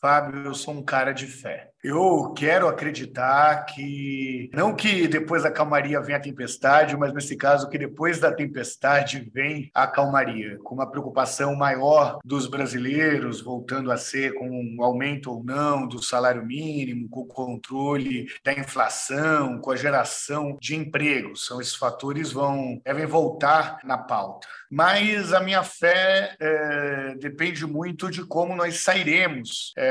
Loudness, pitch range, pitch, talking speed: -23 LUFS, 130-155 Hz, 140 Hz, 155 wpm